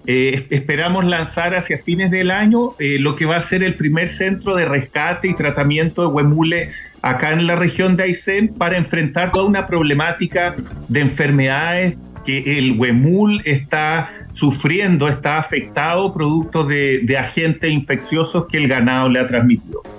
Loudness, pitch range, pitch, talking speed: -16 LUFS, 140-175 Hz, 160 Hz, 160 wpm